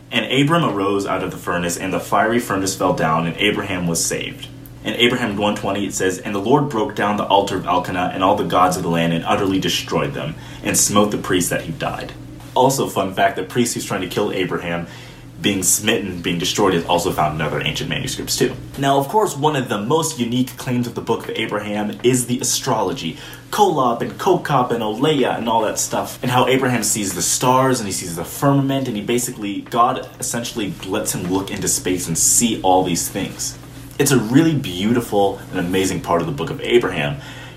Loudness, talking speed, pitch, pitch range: -19 LUFS, 215 wpm, 110 Hz, 95-130 Hz